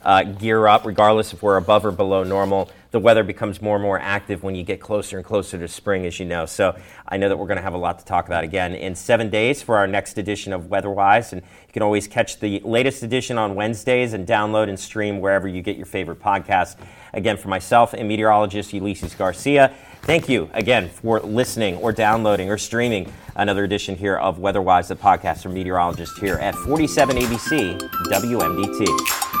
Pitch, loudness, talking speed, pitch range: 100 Hz, -20 LUFS, 205 wpm, 95-110 Hz